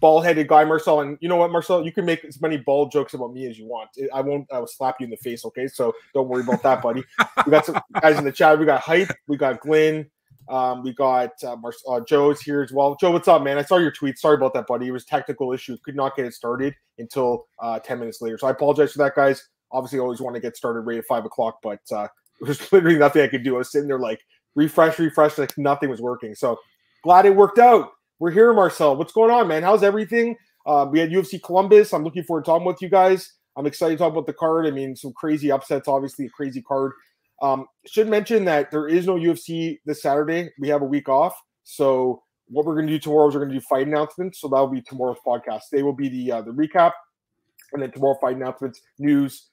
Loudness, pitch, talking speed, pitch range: -20 LUFS, 145 Hz, 260 wpm, 130-165 Hz